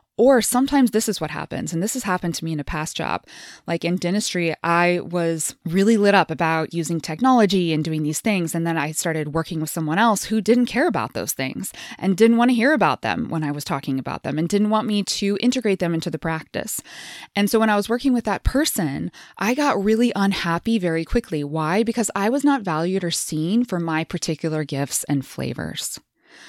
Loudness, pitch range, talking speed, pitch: -21 LUFS, 160-220 Hz, 220 wpm, 175 Hz